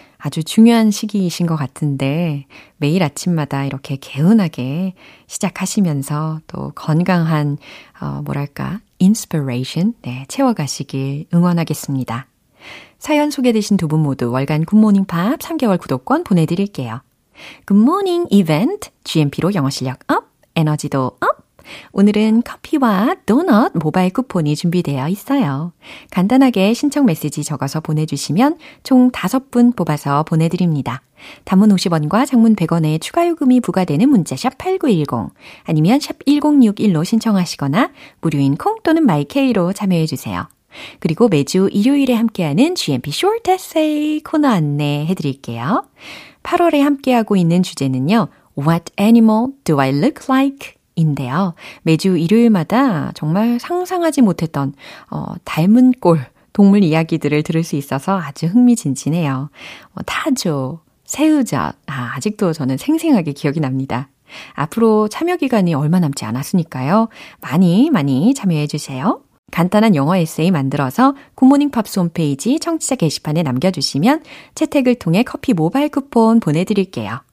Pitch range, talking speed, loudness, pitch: 150-245 Hz, 320 characters per minute, -16 LUFS, 180 Hz